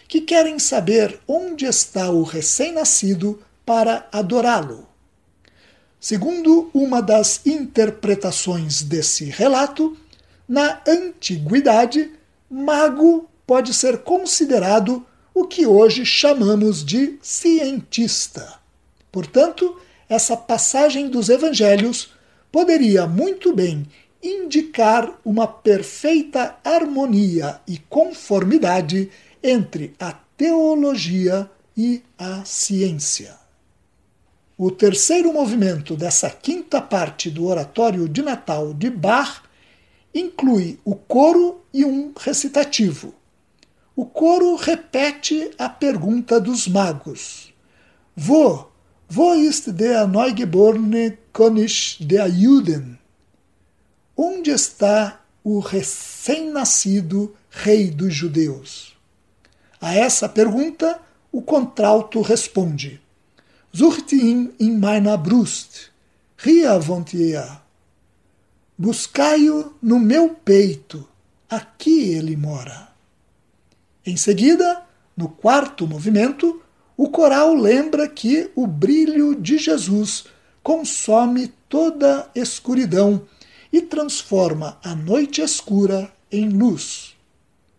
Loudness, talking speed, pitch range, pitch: -18 LUFS, 90 wpm, 185-290 Hz, 225 Hz